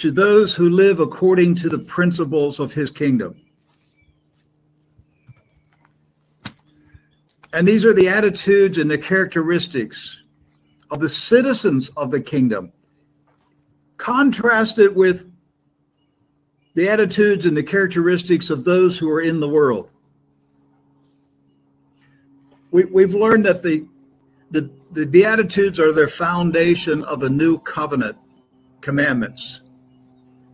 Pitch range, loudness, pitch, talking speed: 130-180 Hz, -17 LUFS, 155 Hz, 110 wpm